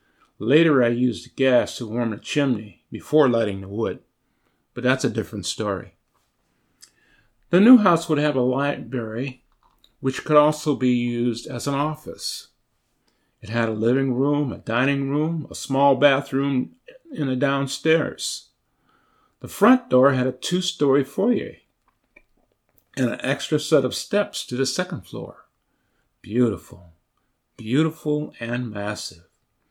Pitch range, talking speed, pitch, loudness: 115-150 Hz, 135 wpm, 130 Hz, -22 LUFS